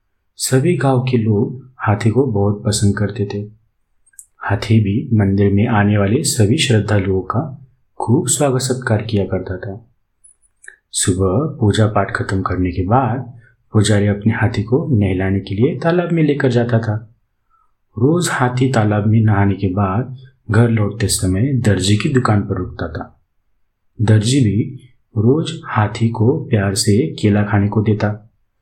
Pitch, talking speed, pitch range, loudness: 110 Hz, 150 wpm, 100-125 Hz, -16 LUFS